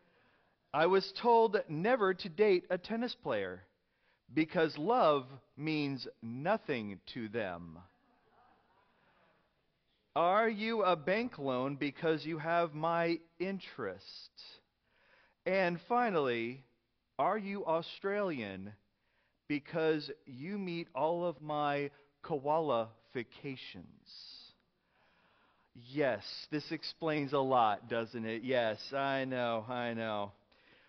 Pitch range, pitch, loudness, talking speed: 125-180 Hz, 150 Hz, -35 LUFS, 95 wpm